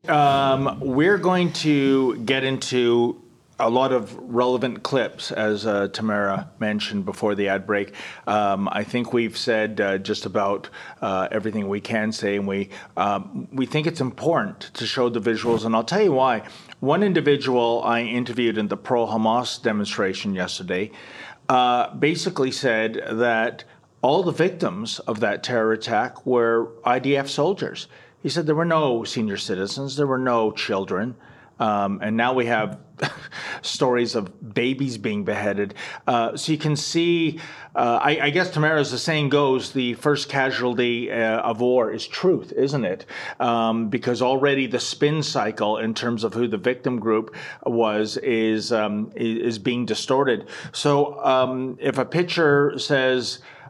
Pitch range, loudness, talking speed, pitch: 110-140 Hz, -22 LUFS, 160 wpm, 125 Hz